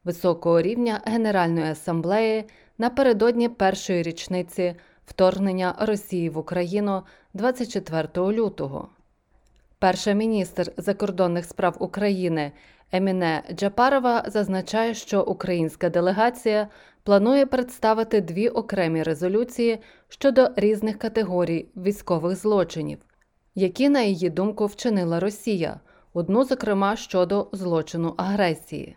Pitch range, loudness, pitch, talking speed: 175-220 Hz, -23 LUFS, 195 Hz, 95 wpm